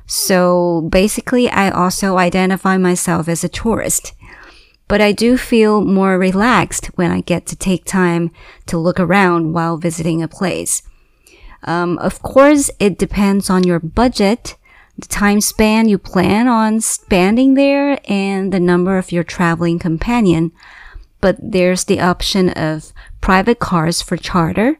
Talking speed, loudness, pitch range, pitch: 145 wpm, -14 LUFS, 175-205 Hz, 185 Hz